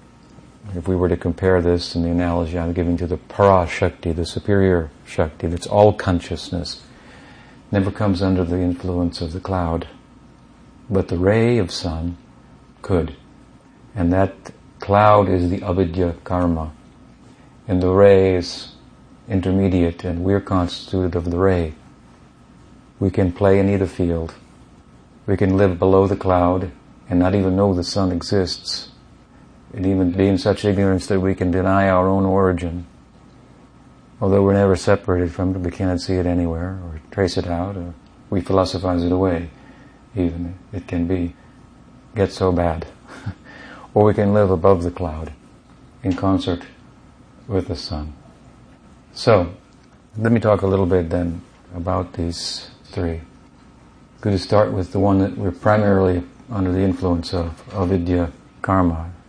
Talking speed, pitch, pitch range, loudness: 155 wpm, 90 Hz, 85-95 Hz, -19 LUFS